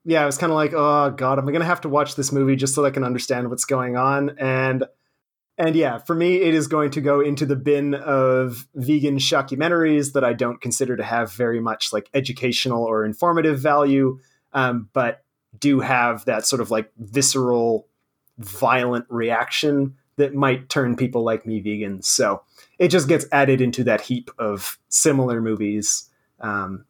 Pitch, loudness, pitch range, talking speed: 135 Hz, -20 LUFS, 120-145 Hz, 185 wpm